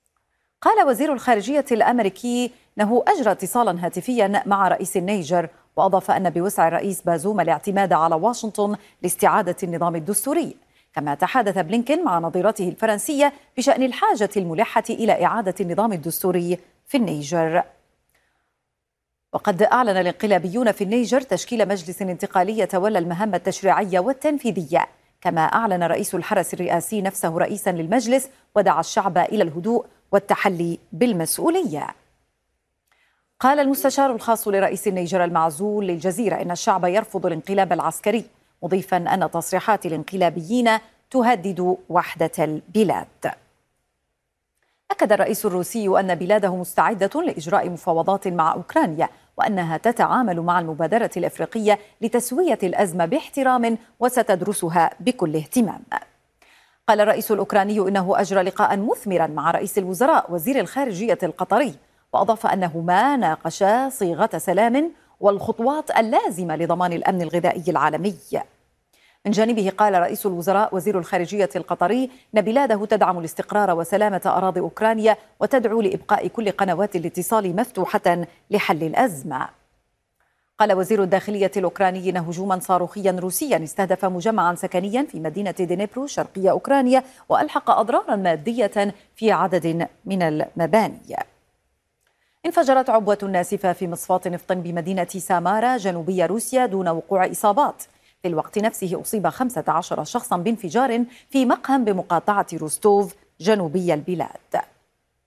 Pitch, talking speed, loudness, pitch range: 195 Hz, 115 wpm, -21 LUFS, 175-225 Hz